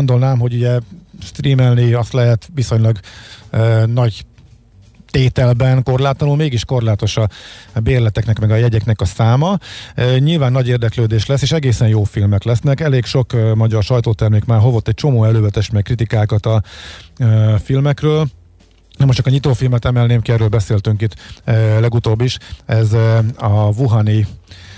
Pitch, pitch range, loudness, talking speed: 115 Hz, 110-125 Hz, -15 LUFS, 145 wpm